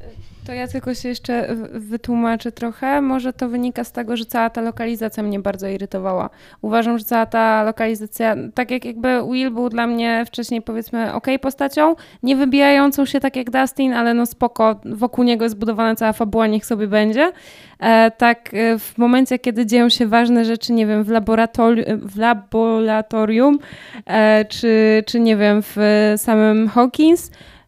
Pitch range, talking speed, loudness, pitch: 220-245 Hz, 165 wpm, -17 LUFS, 230 Hz